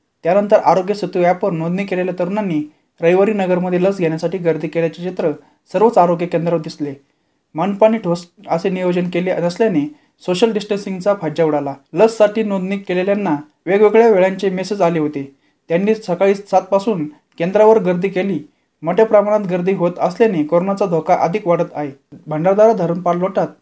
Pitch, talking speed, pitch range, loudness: 180 Hz, 140 wpm, 165-200 Hz, -16 LUFS